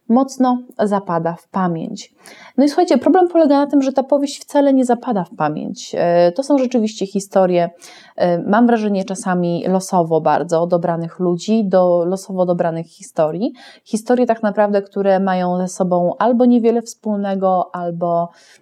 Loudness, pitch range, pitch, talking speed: -17 LUFS, 175-245 Hz, 195 Hz, 145 wpm